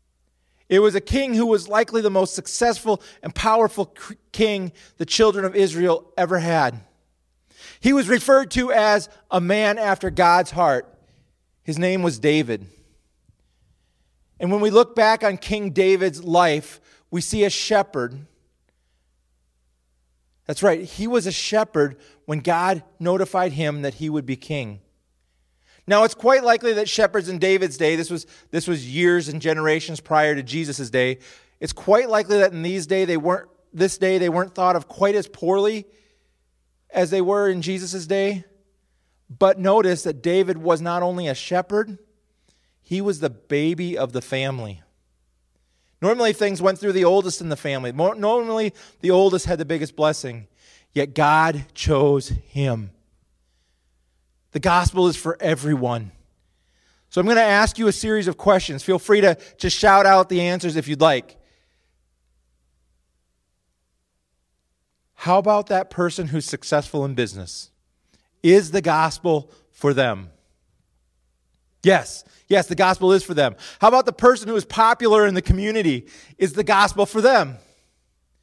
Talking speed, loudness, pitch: 155 wpm, -20 LUFS, 170 Hz